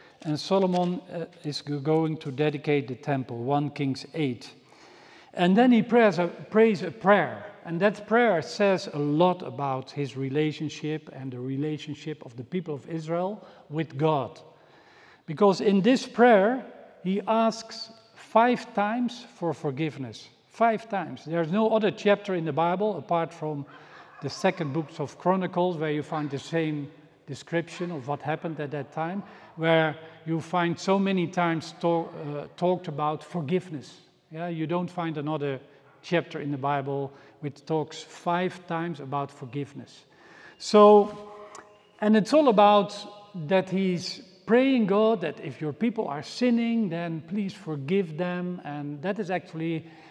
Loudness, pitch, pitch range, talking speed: -26 LUFS, 170 Hz, 150-200 Hz, 150 wpm